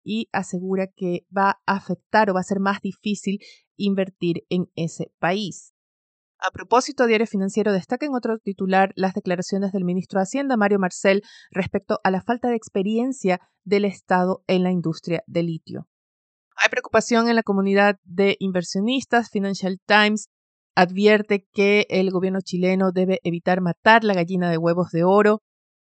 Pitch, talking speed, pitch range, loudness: 195 Hz, 160 wpm, 180-210 Hz, -21 LUFS